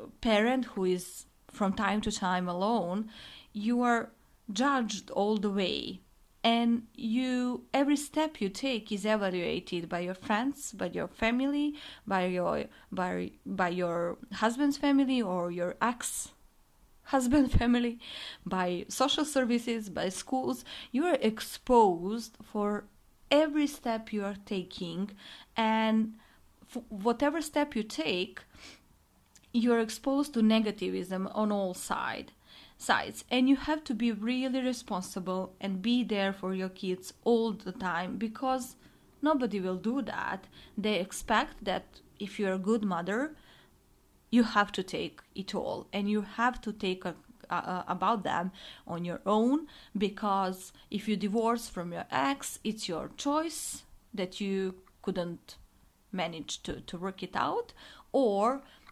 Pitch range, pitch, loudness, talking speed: 190-250 Hz, 215 Hz, -31 LUFS, 140 wpm